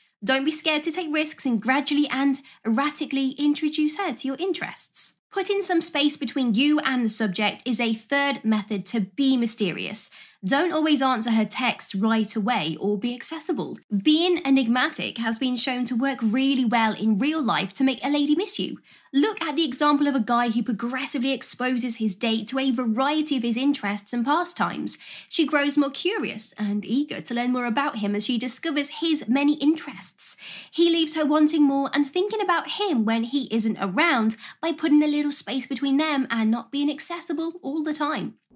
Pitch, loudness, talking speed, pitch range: 270 Hz, -24 LUFS, 190 wpm, 235-300 Hz